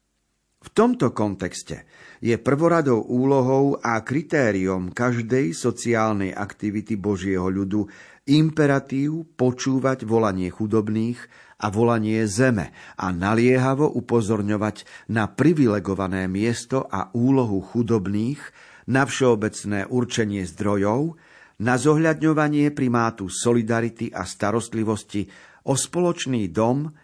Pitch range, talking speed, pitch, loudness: 105-130 Hz, 95 wpm, 115 Hz, -22 LUFS